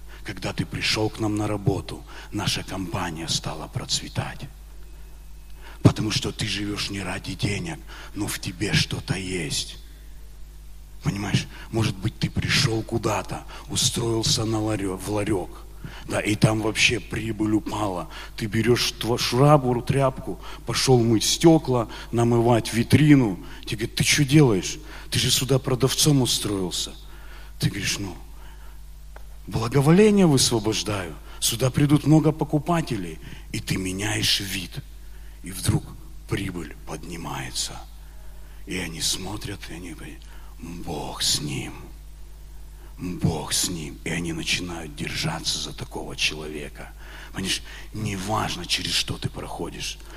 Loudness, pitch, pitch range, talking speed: -23 LUFS, 115 Hz, 100-130 Hz, 120 wpm